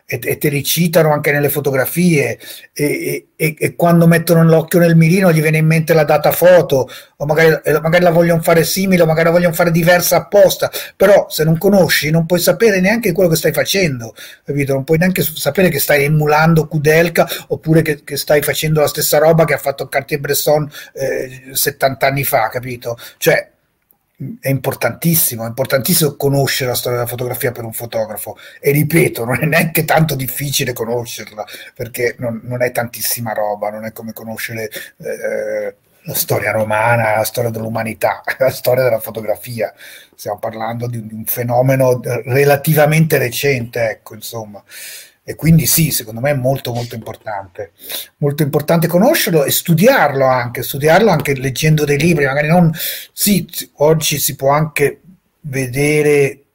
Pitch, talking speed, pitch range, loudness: 145 Hz, 165 wpm, 125-165 Hz, -14 LUFS